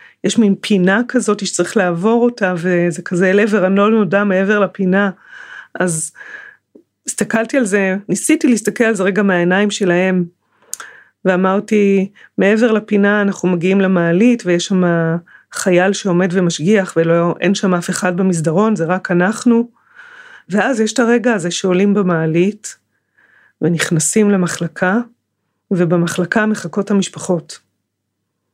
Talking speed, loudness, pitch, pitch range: 120 wpm, -15 LUFS, 195 Hz, 175-215 Hz